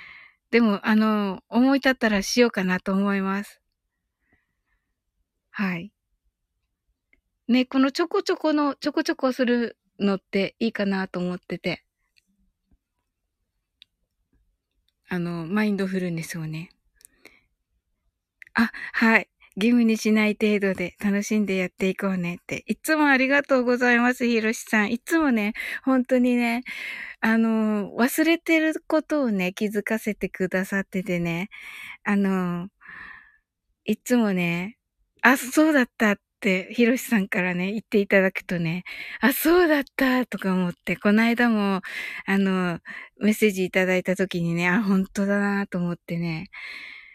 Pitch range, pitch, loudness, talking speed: 185-245 Hz, 210 Hz, -23 LUFS, 270 characters per minute